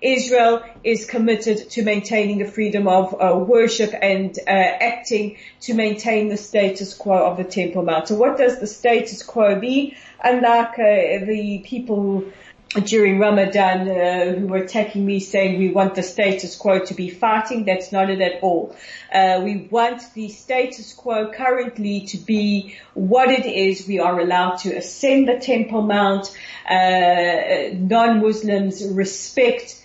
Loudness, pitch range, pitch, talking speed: -19 LUFS, 190-230 Hz, 205 Hz, 155 wpm